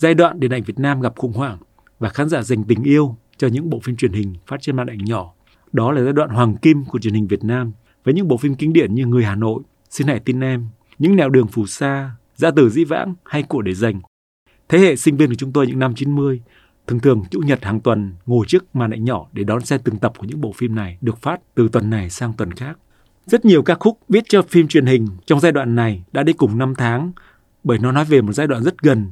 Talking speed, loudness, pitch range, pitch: 270 wpm, -17 LUFS, 110-150 Hz, 125 Hz